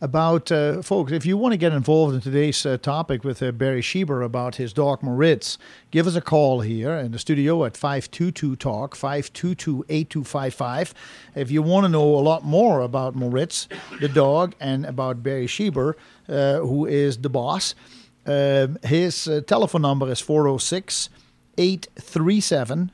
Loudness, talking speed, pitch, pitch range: -22 LUFS, 165 wpm, 145 Hz, 135-165 Hz